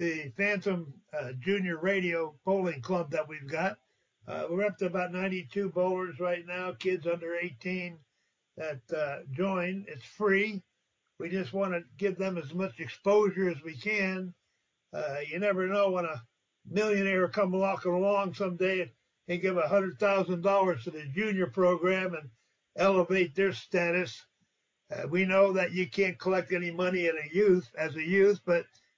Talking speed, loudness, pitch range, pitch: 165 wpm, -30 LUFS, 170-195 Hz, 185 Hz